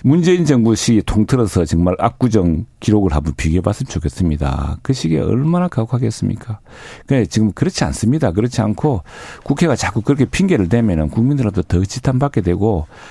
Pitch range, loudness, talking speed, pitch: 95-130 Hz, -16 LUFS, 405 characters per minute, 110 Hz